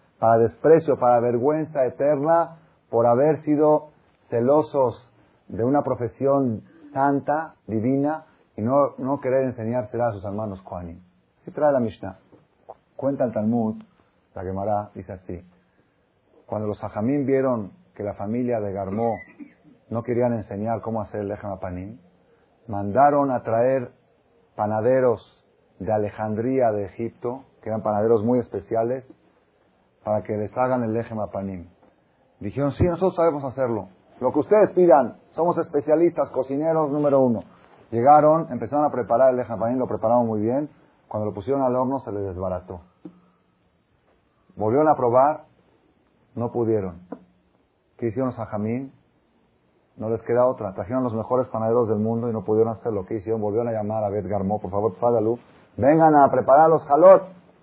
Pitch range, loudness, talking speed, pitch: 105-135 Hz, -22 LUFS, 145 wpm, 115 Hz